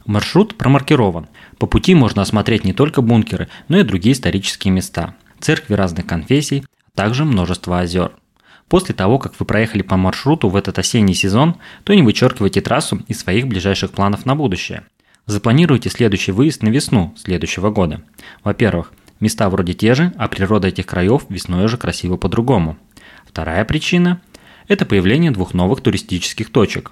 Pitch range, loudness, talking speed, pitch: 95-135 Hz, -16 LUFS, 155 wpm, 105 Hz